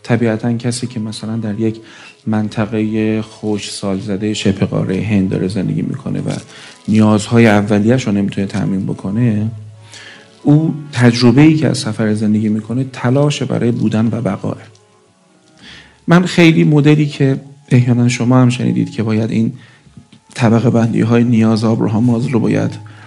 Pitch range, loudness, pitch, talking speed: 105-120 Hz, -14 LUFS, 110 Hz, 135 wpm